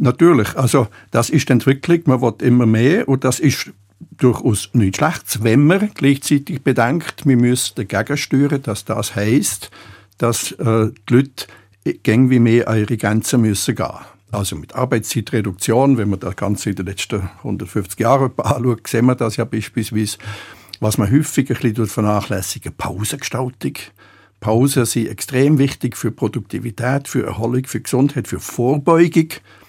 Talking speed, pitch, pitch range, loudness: 150 wpm, 120 Hz, 110-135 Hz, -17 LUFS